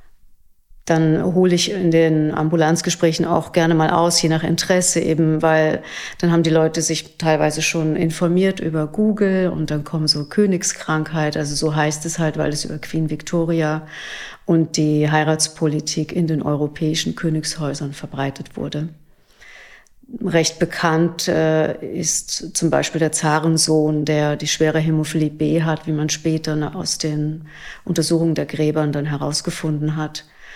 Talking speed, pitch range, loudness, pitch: 145 wpm, 155-165 Hz, -19 LUFS, 160 Hz